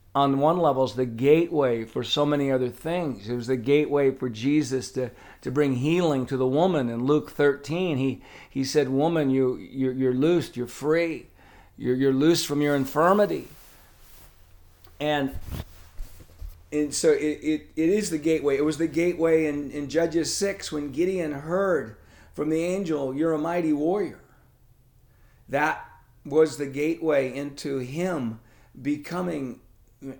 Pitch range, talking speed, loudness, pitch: 125-155 Hz, 155 wpm, -25 LUFS, 145 Hz